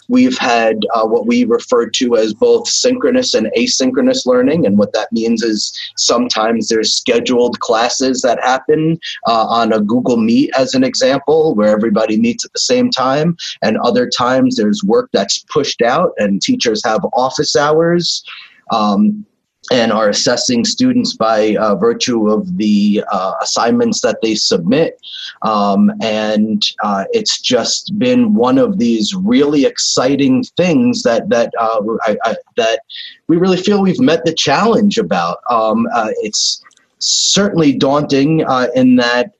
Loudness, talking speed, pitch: -13 LUFS, 155 wpm, 180 Hz